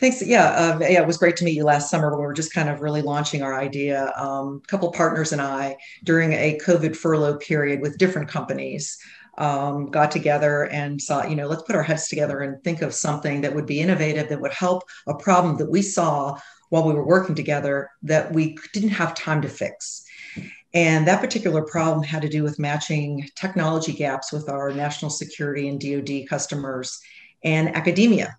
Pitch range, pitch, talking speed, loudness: 145-165 Hz, 150 Hz, 205 wpm, -22 LUFS